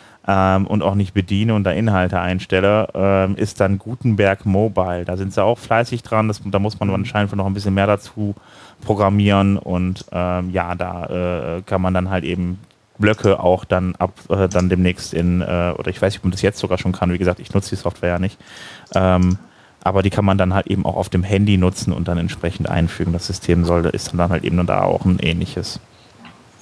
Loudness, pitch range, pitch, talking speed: -19 LUFS, 90-100 Hz, 95 Hz, 220 wpm